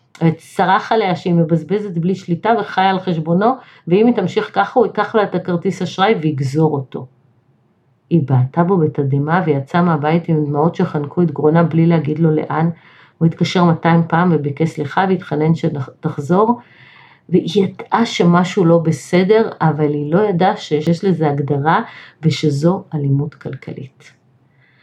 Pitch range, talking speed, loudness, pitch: 150-185 Hz, 145 wpm, -16 LUFS, 165 Hz